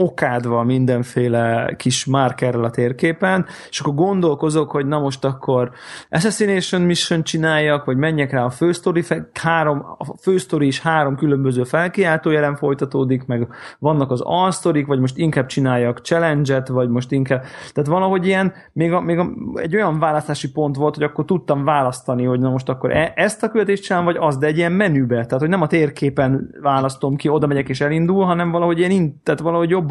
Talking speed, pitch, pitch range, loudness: 180 wpm, 150 Hz, 130-170 Hz, -18 LUFS